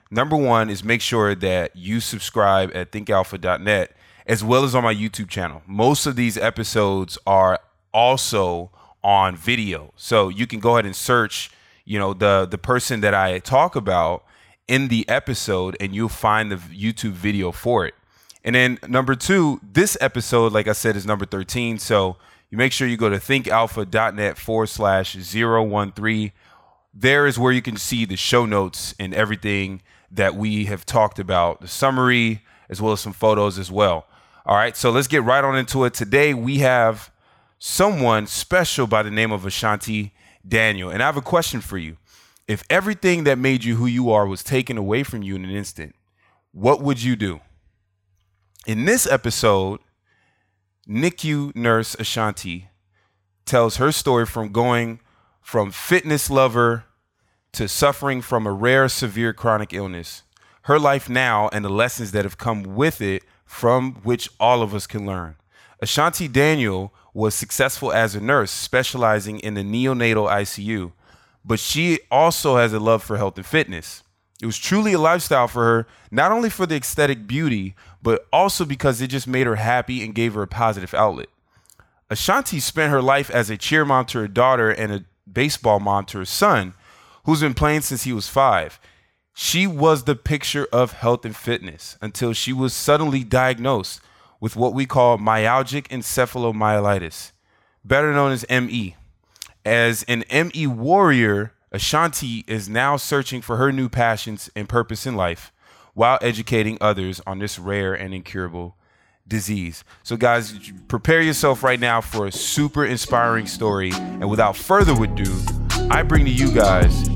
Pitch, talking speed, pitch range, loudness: 115 Hz, 170 wpm, 100-130 Hz, -20 LUFS